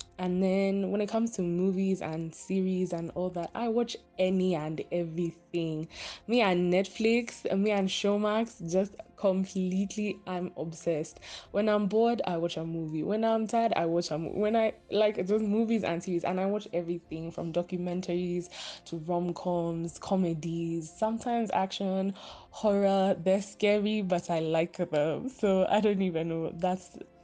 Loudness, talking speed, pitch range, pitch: -30 LUFS, 160 wpm, 170-205 Hz, 185 Hz